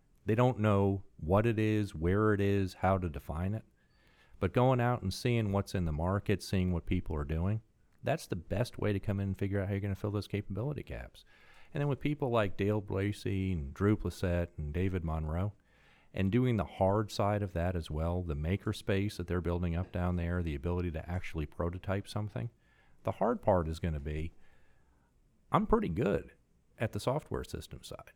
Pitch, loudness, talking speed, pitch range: 95 Hz, -34 LUFS, 205 wpm, 85-105 Hz